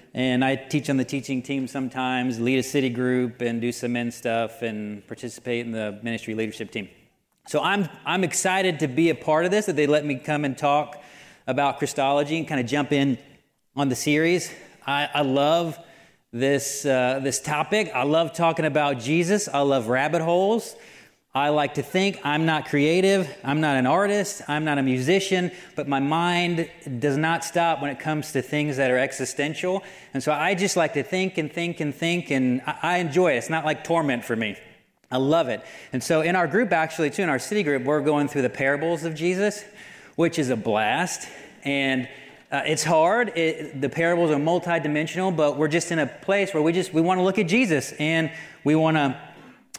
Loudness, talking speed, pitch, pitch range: -23 LUFS, 205 wpm, 150 Hz, 135-170 Hz